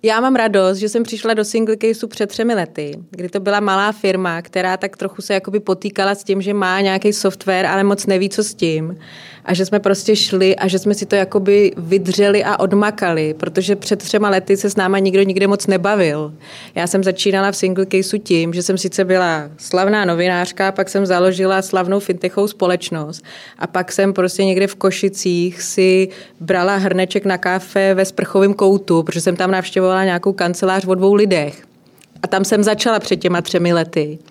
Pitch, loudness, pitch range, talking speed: 190 Hz, -16 LUFS, 185-200 Hz, 195 wpm